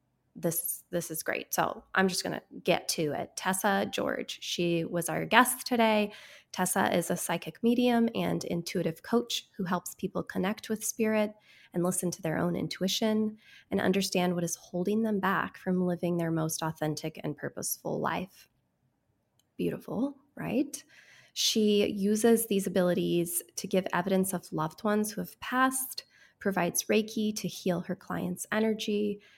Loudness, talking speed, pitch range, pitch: -30 LUFS, 155 wpm, 175-215 Hz, 190 Hz